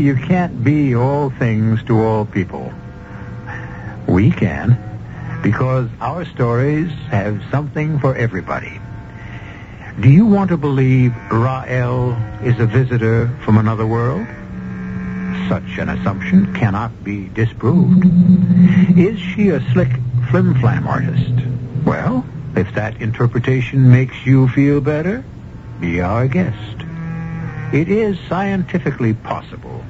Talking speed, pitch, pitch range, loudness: 110 wpm, 125 Hz, 110-150 Hz, -16 LUFS